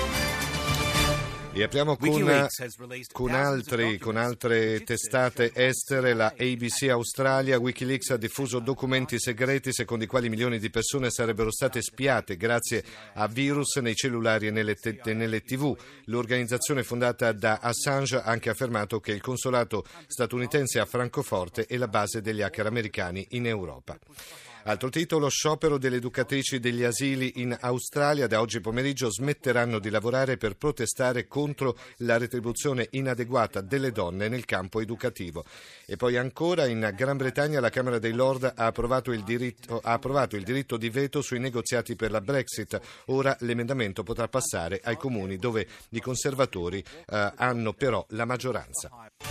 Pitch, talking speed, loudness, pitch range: 125 Hz, 150 wpm, -28 LUFS, 115-130 Hz